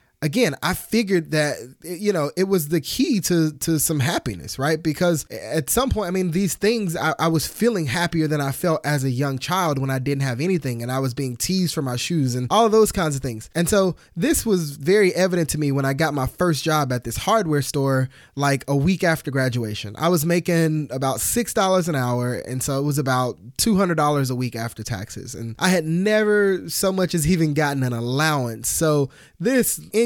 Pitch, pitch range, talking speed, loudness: 155 Hz, 135-180 Hz, 225 wpm, -21 LUFS